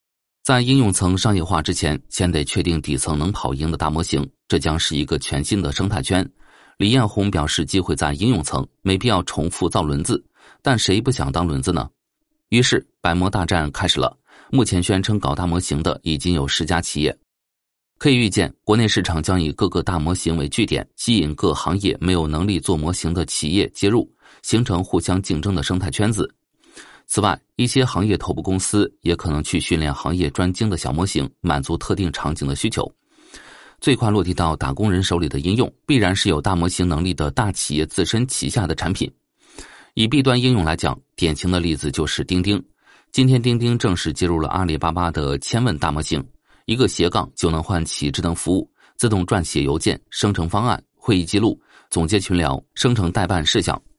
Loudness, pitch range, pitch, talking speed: -20 LUFS, 80-105 Hz, 90 Hz, 300 characters per minute